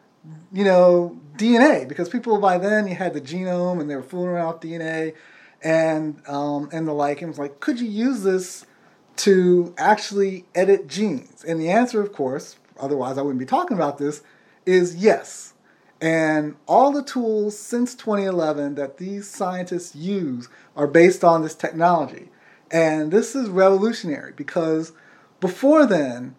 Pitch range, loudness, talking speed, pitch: 155-205 Hz, -21 LUFS, 160 wpm, 175 Hz